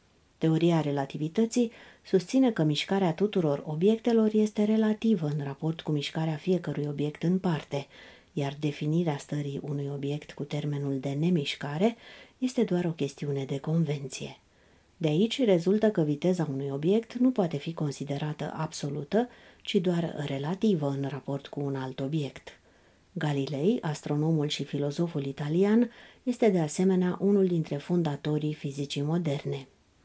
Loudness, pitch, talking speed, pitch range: -29 LUFS, 155 Hz, 130 wpm, 145-190 Hz